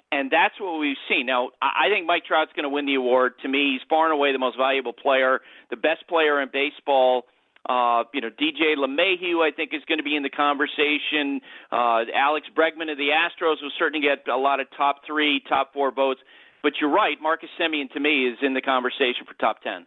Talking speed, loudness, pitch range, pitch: 225 wpm, -22 LUFS, 135-155 Hz, 145 Hz